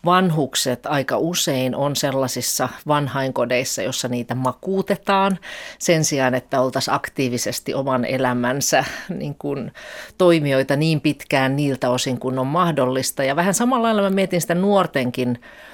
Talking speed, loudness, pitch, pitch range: 130 wpm, -20 LUFS, 140 Hz, 130-175 Hz